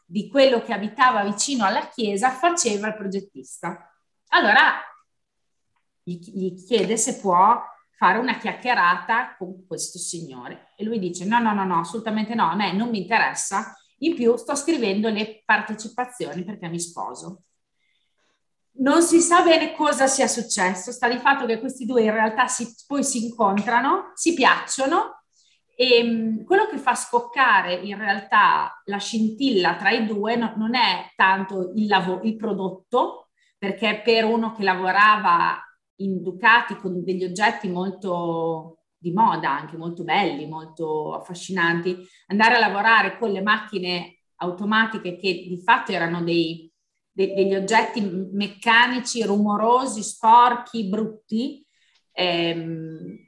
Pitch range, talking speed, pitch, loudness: 185-240 Hz, 135 wpm, 215 Hz, -21 LUFS